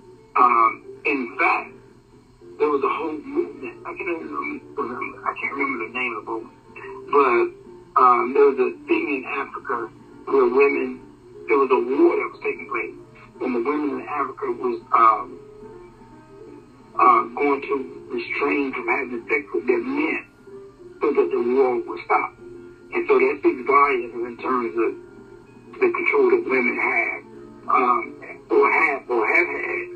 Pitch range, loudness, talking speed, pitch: 360-390 Hz, -21 LUFS, 160 wpm, 370 Hz